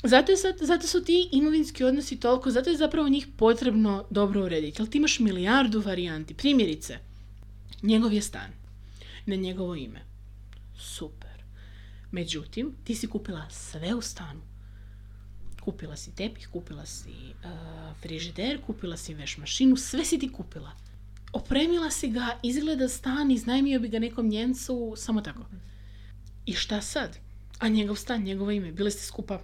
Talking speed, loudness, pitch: 150 wpm, -27 LUFS, 200 Hz